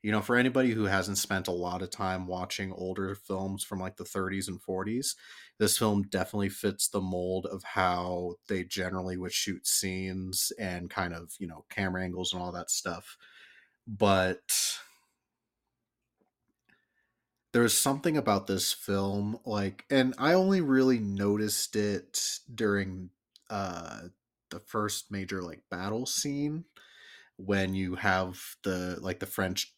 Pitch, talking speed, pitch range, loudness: 95 Hz, 145 wpm, 95-105 Hz, -30 LUFS